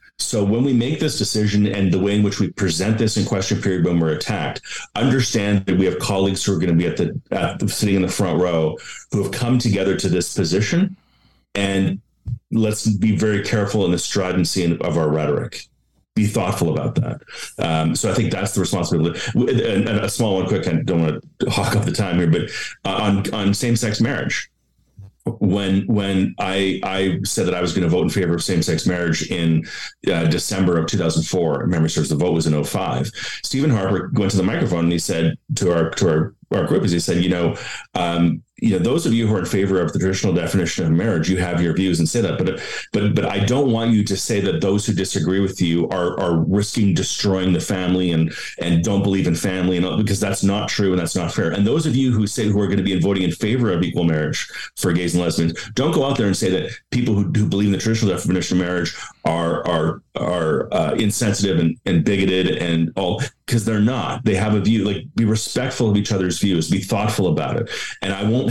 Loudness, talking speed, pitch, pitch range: -19 LUFS, 235 wpm, 100 Hz, 90-105 Hz